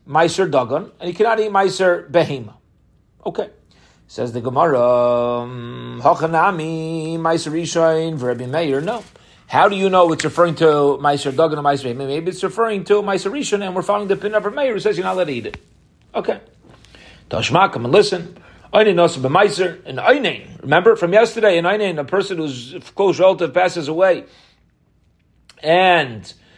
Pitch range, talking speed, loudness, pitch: 140-195 Hz, 160 wpm, -17 LUFS, 170 Hz